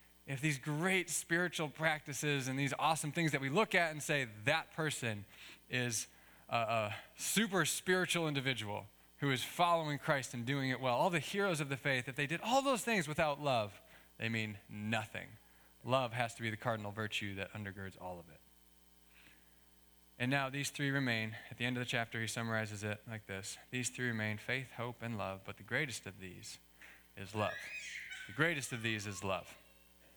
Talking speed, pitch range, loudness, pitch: 190 wpm, 105-150 Hz, -37 LUFS, 125 Hz